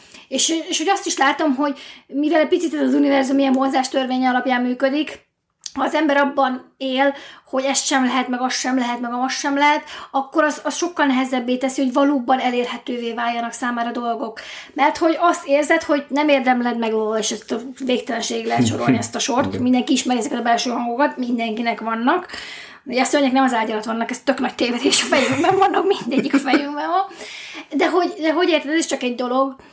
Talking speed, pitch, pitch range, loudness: 195 wpm, 270 Hz, 250-295 Hz, -19 LUFS